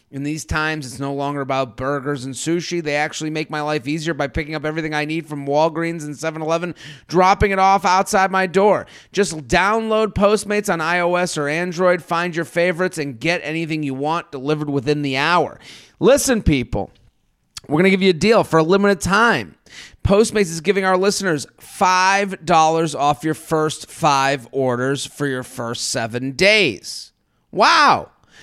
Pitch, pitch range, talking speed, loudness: 160 Hz, 145-185 Hz, 175 wpm, -18 LUFS